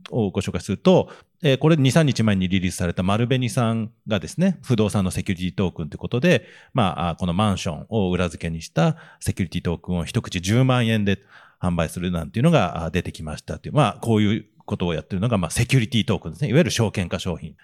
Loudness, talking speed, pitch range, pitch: -22 LUFS, 490 characters per minute, 90-120 Hz, 100 Hz